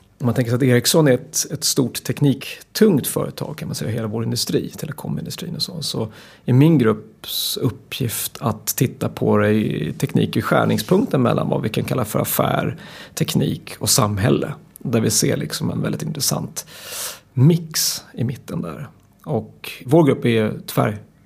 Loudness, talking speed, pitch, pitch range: -20 LUFS, 165 wpm, 125 Hz, 110-135 Hz